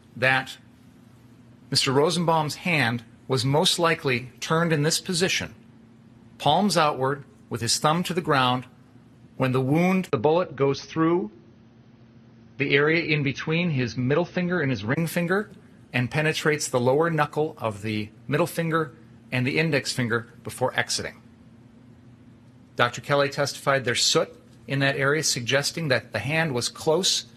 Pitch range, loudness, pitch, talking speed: 120-155 Hz, -24 LUFS, 130 Hz, 145 wpm